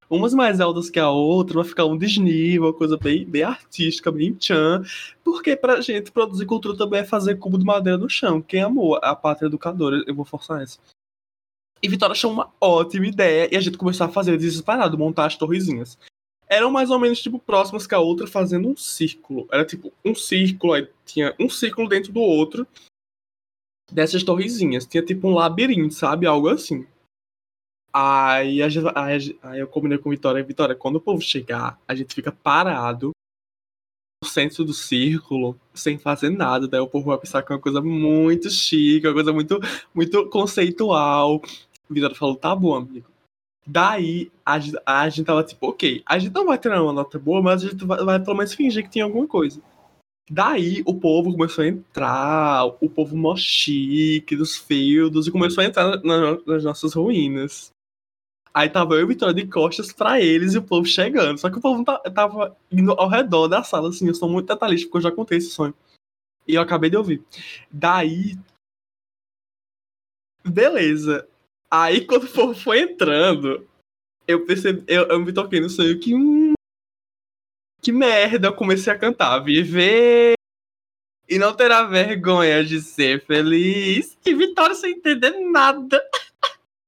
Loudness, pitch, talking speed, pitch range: -19 LUFS, 175 Hz, 175 wpm, 155-215 Hz